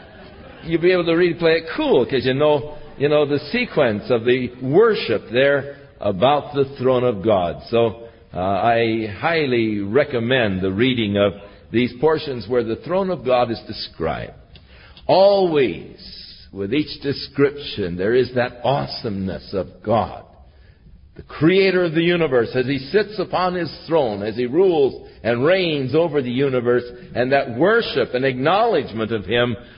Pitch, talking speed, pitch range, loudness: 135 Hz, 155 wpm, 115-160 Hz, -19 LUFS